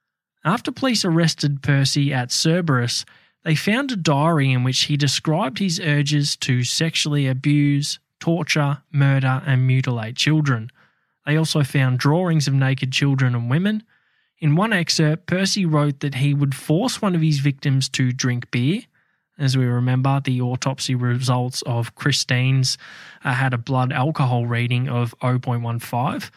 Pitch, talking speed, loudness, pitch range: 140 Hz, 150 wpm, -20 LUFS, 130-155 Hz